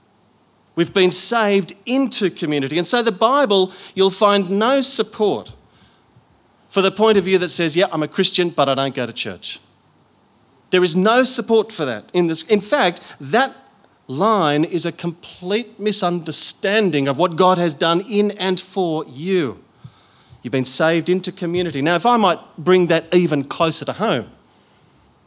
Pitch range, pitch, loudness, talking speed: 160-205 Hz, 180 Hz, -17 LUFS, 165 wpm